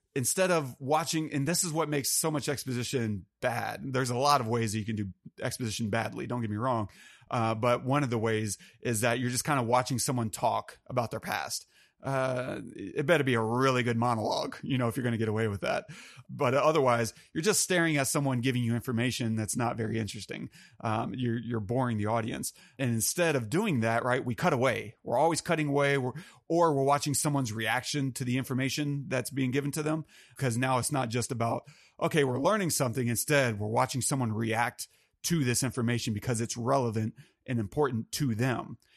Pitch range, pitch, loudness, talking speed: 115-140 Hz, 125 Hz, -30 LUFS, 210 wpm